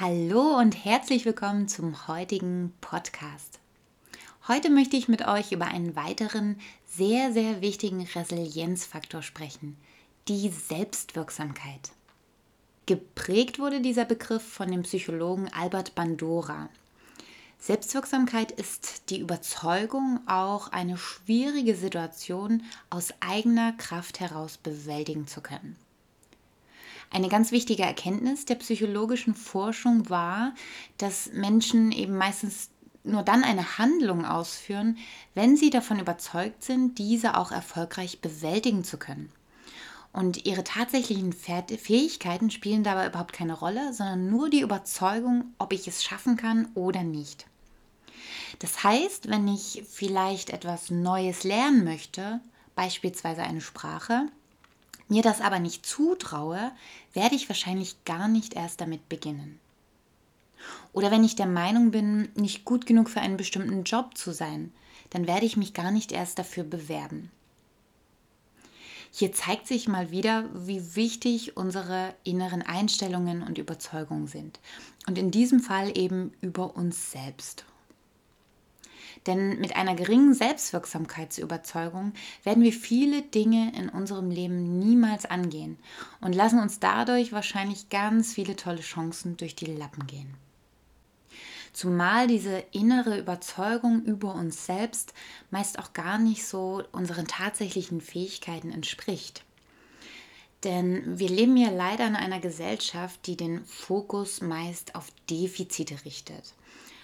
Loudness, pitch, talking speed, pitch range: -28 LUFS, 195 Hz, 125 wpm, 175-225 Hz